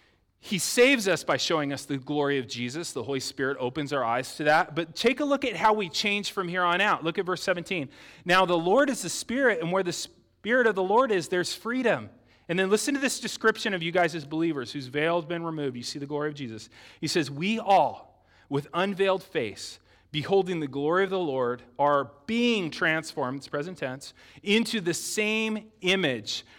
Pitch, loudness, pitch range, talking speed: 170 Hz, -26 LUFS, 140-200 Hz, 215 wpm